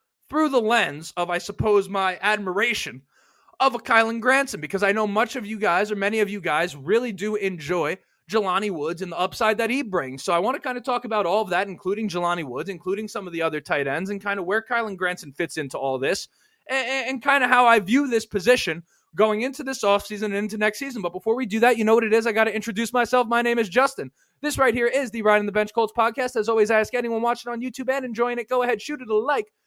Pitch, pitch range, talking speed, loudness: 220 Hz, 195-245 Hz, 265 wpm, -23 LUFS